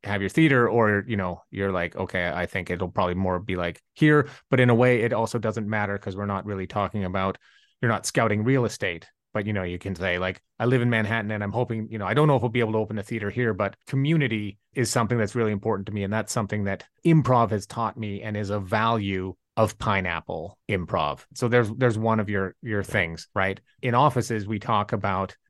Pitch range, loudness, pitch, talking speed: 100-120 Hz, -25 LUFS, 105 Hz, 240 wpm